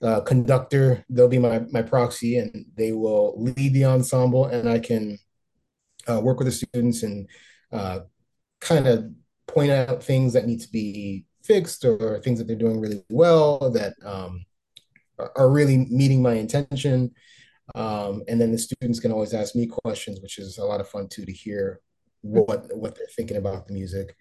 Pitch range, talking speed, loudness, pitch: 105-130 Hz, 180 wpm, -23 LUFS, 115 Hz